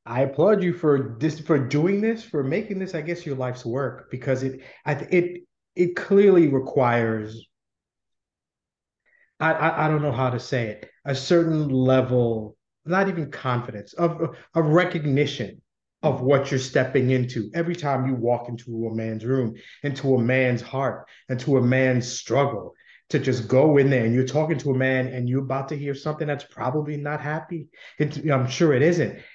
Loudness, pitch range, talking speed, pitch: -23 LUFS, 125-160 Hz, 180 wpm, 140 Hz